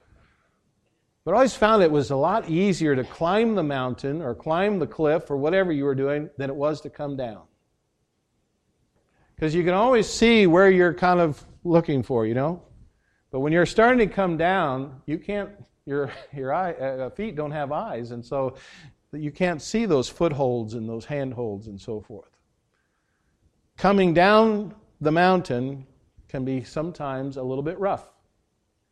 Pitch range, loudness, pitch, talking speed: 135-180 Hz, -23 LUFS, 150 Hz, 170 wpm